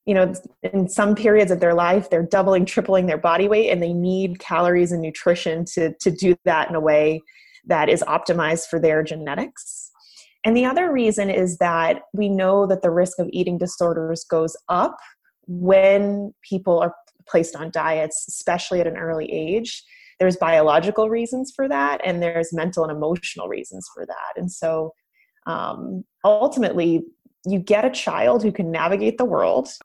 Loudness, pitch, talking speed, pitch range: -20 LUFS, 180 Hz, 175 wpm, 165-200 Hz